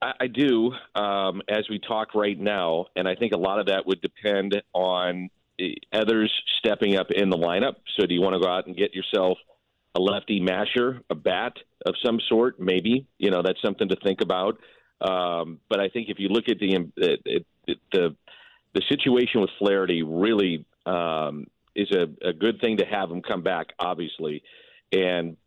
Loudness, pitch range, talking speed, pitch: -25 LUFS, 90-110 Hz, 190 wpm, 100 Hz